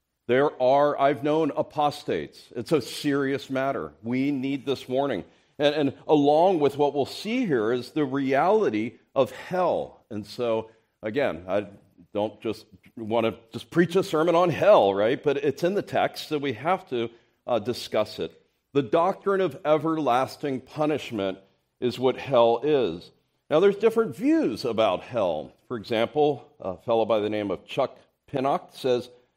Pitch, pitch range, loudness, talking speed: 135 Hz, 115-150 Hz, -25 LUFS, 160 wpm